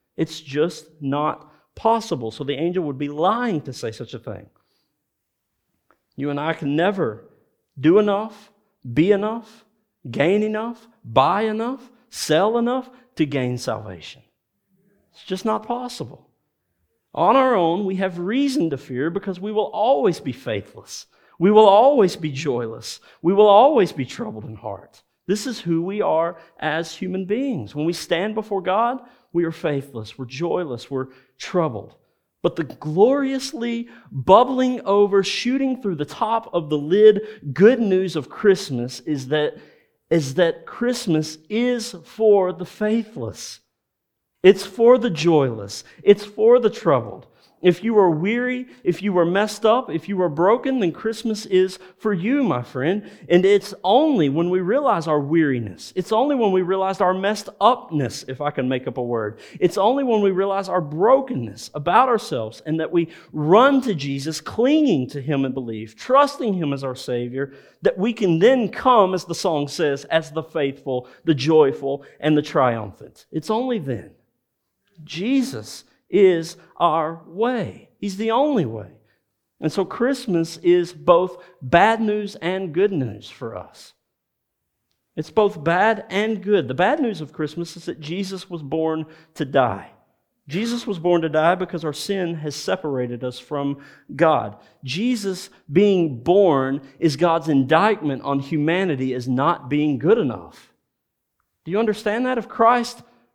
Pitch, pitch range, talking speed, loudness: 175 Hz, 145-210 Hz, 160 wpm, -20 LUFS